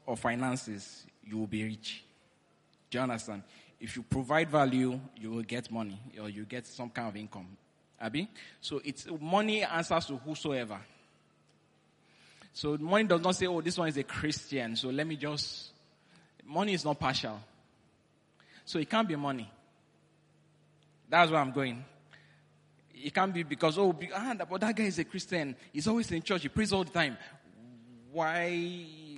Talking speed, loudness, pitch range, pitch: 160 wpm, -33 LUFS, 120-170 Hz, 145 Hz